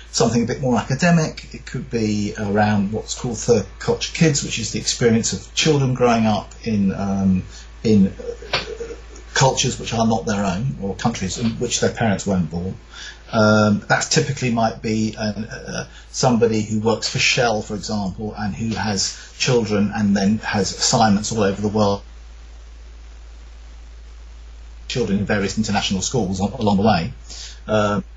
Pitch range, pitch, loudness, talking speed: 95-115 Hz, 105 Hz, -20 LUFS, 160 wpm